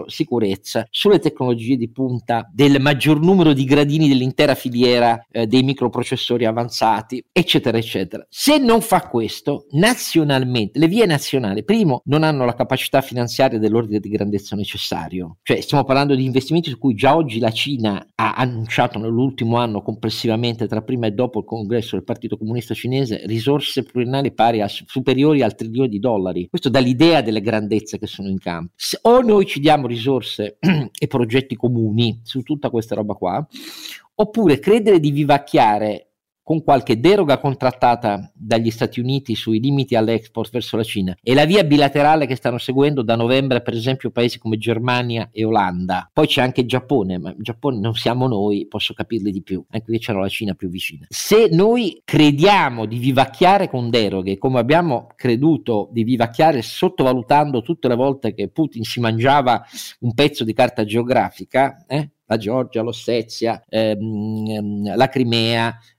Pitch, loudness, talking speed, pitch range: 120 Hz, -18 LUFS, 165 wpm, 110-140 Hz